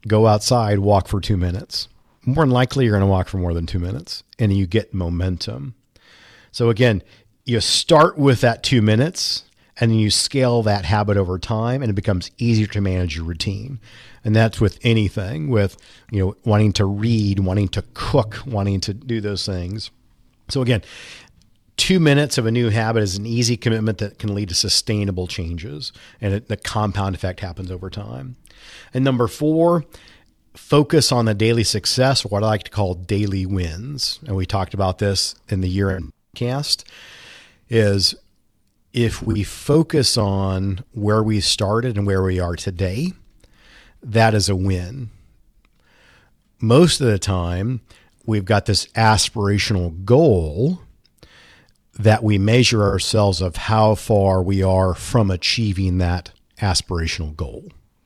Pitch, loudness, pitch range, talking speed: 105 Hz, -19 LUFS, 95-115 Hz, 160 wpm